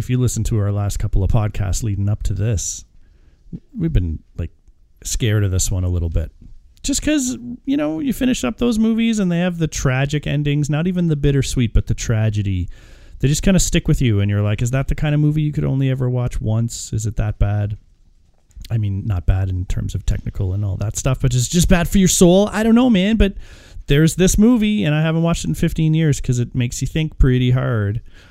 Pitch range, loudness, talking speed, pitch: 100-160 Hz, -18 LUFS, 240 wpm, 125 Hz